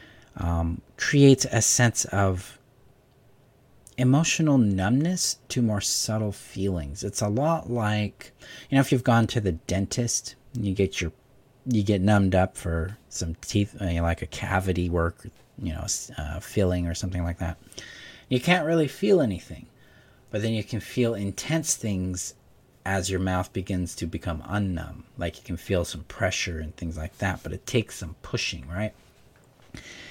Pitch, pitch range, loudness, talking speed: 100 Hz, 90-125 Hz, -26 LUFS, 160 wpm